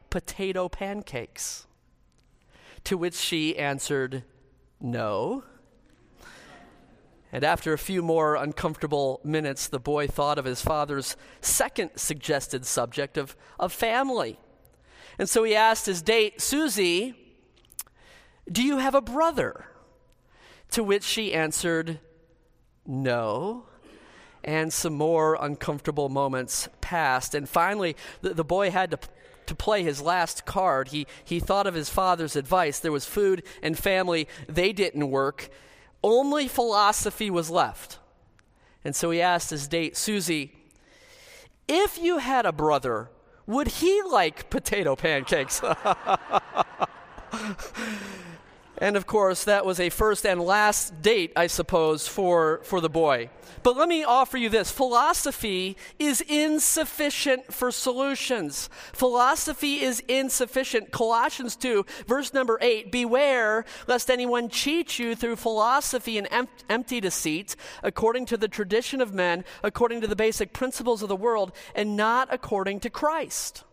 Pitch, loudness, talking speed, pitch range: 200 Hz, -25 LUFS, 130 wpm, 160-245 Hz